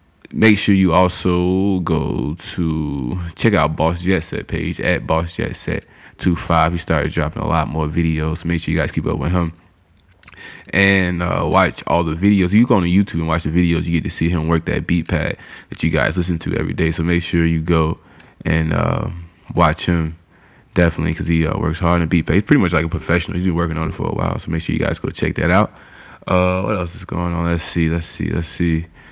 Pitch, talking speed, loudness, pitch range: 85 Hz, 240 wpm, -18 LUFS, 80-90 Hz